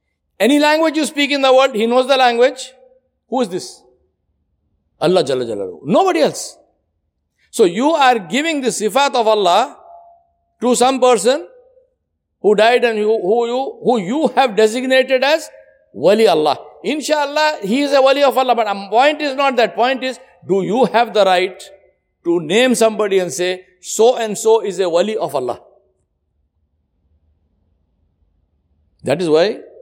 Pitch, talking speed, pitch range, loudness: 240 Hz, 155 wpm, 185-270 Hz, -15 LUFS